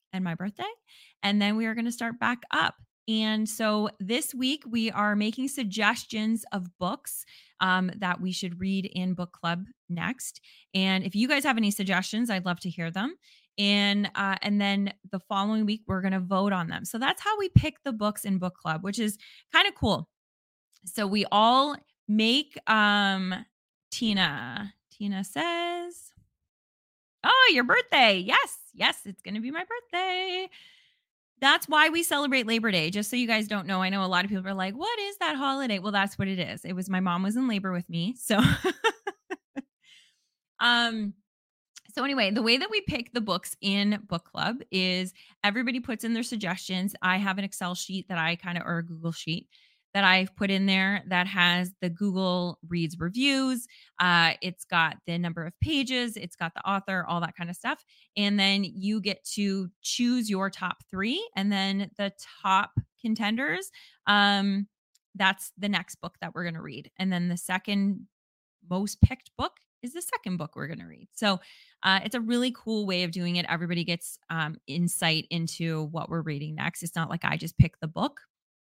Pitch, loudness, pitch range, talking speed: 200 Hz, -27 LUFS, 185-235 Hz, 190 wpm